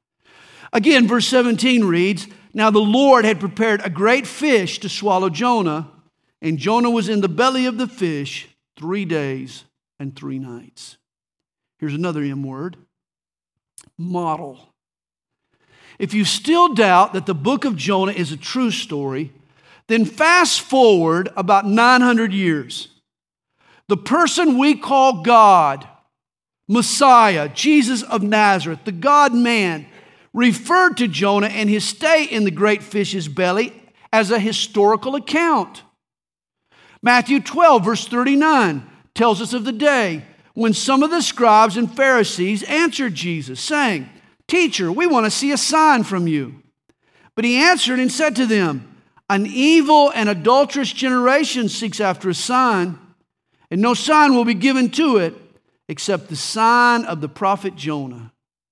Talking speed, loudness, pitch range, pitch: 140 wpm, -16 LUFS, 180-255 Hz, 220 Hz